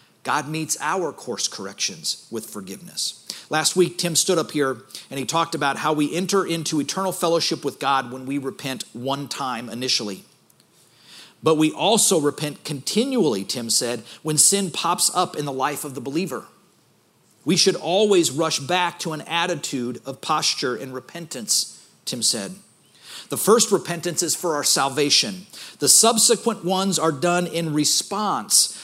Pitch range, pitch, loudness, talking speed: 135-175 Hz, 155 Hz, -21 LUFS, 160 wpm